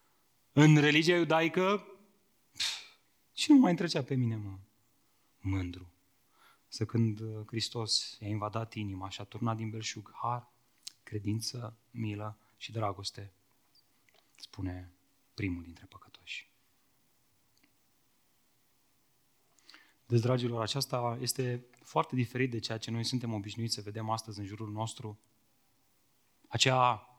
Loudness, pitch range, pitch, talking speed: -32 LUFS, 105-125 Hz, 115 Hz, 115 wpm